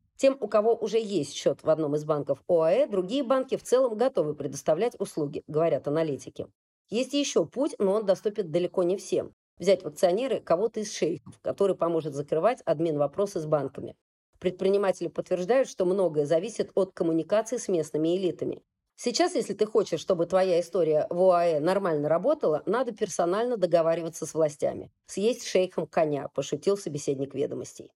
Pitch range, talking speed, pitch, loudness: 160-215 Hz, 160 wpm, 185 Hz, -27 LUFS